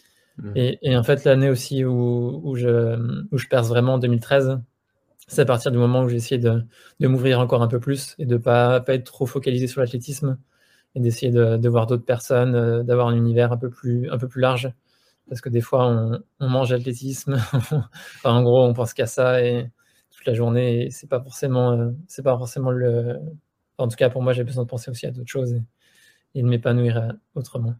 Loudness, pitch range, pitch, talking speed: -21 LUFS, 120-130 Hz, 125 Hz, 220 wpm